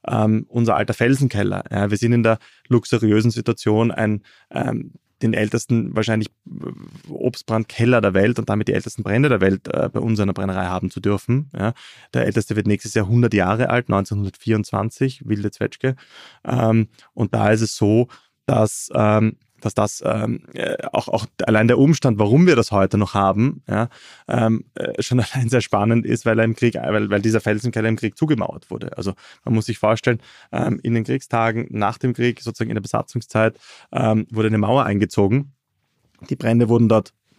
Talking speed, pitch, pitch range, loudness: 180 wpm, 110 Hz, 105-120 Hz, -20 LUFS